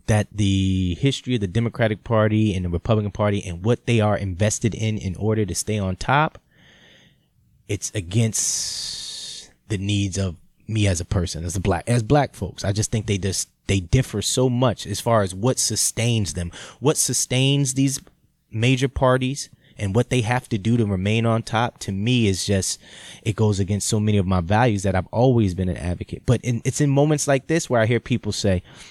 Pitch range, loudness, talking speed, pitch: 100-125 Hz, -22 LUFS, 205 wpm, 110 Hz